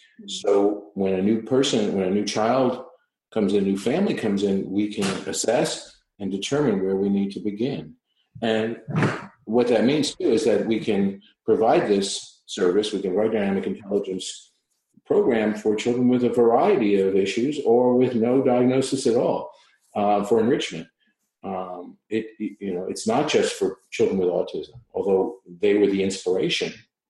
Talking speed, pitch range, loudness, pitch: 175 wpm, 100-125 Hz, -23 LUFS, 110 Hz